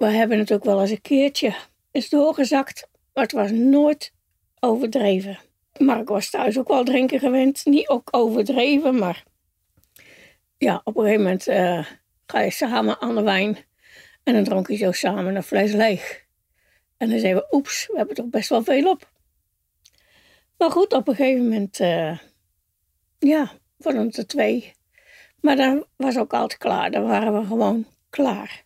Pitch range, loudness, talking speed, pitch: 200-275 Hz, -21 LUFS, 180 wpm, 230 Hz